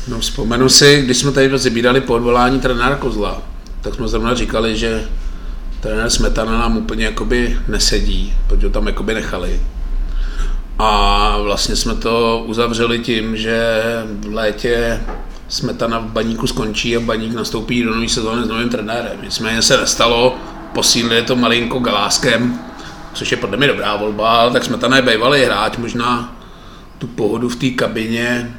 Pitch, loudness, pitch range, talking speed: 115 Hz, -15 LUFS, 110-120 Hz, 155 wpm